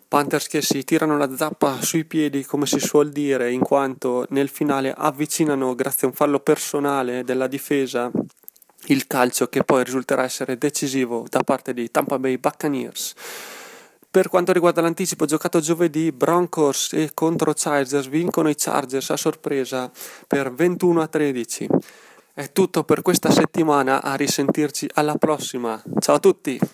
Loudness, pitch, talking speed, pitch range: -21 LUFS, 145 Hz, 155 wpm, 135-160 Hz